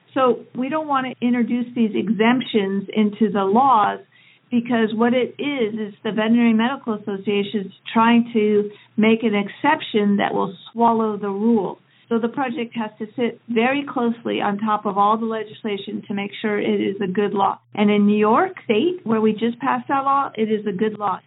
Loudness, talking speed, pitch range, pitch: -20 LUFS, 195 wpm, 210-235 Hz, 220 Hz